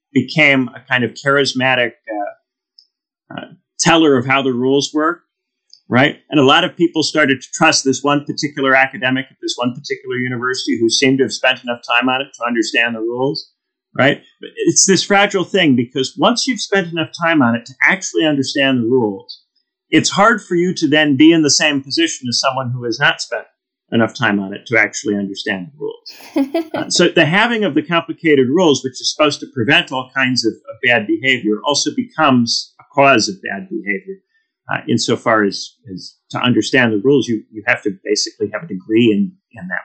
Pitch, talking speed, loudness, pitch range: 140 Hz, 200 wpm, -15 LUFS, 125-185 Hz